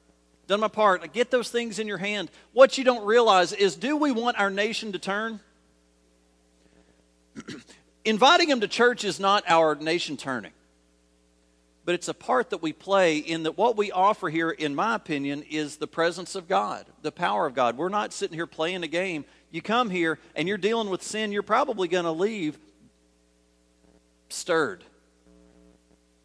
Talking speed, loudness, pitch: 175 wpm, -25 LUFS, 170 Hz